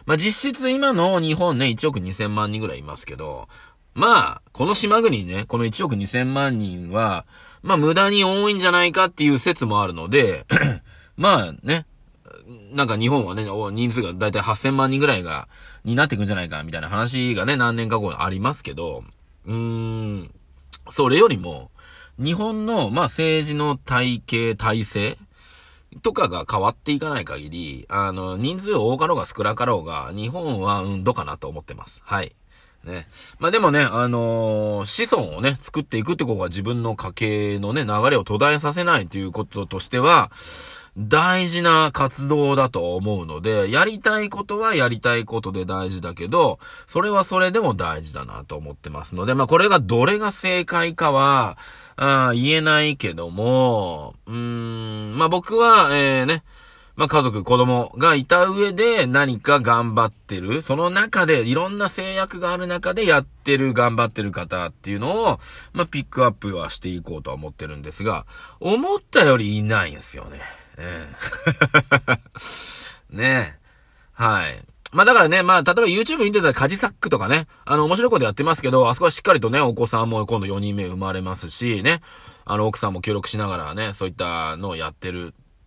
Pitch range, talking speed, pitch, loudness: 105-155 Hz, 335 characters per minute, 120 Hz, -20 LUFS